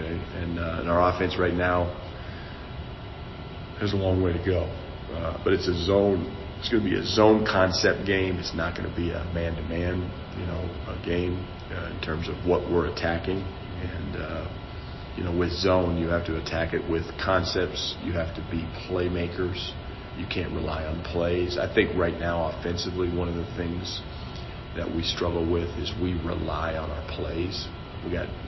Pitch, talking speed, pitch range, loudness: 90 Hz, 185 wpm, 85-90 Hz, -27 LUFS